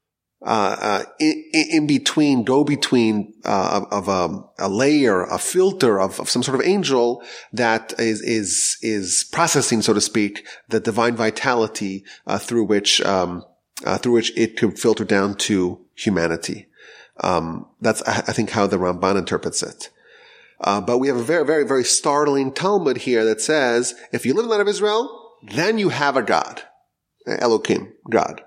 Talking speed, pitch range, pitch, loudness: 175 wpm, 105-150 Hz, 115 Hz, -19 LUFS